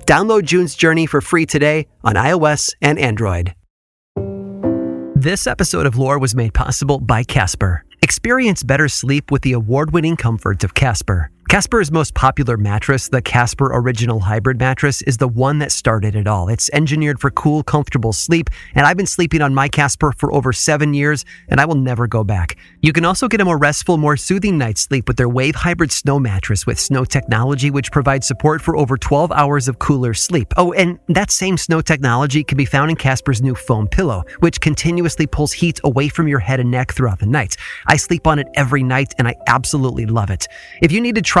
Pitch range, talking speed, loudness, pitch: 120-155 Hz, 205 wpm, -15 LUFS, 140 Hz